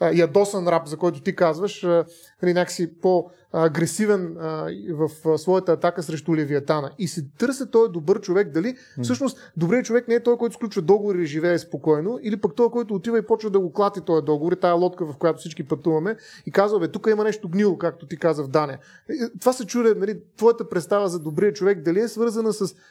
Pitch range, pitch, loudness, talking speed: 165-215 Hz, 185 Hz, -22 LUFS, 195 wpm